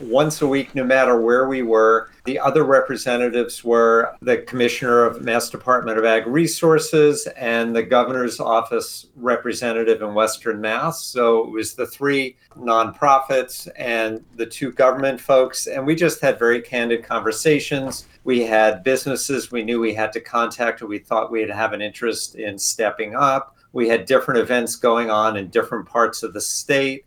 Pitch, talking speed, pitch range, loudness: 120 Hz, 170 wpm, 115-135 Hz, -19 LUFS